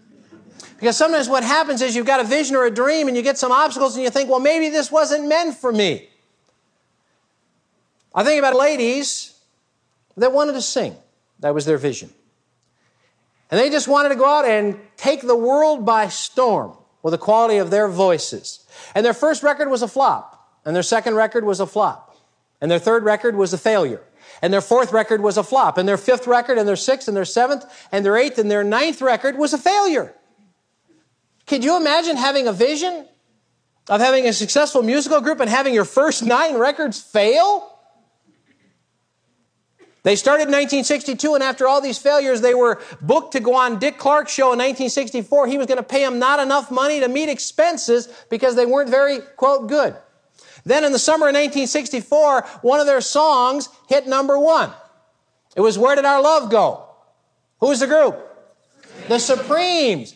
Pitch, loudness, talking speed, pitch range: 265 Hz, -17 LUFS, 190 wpm, 235-290 Hz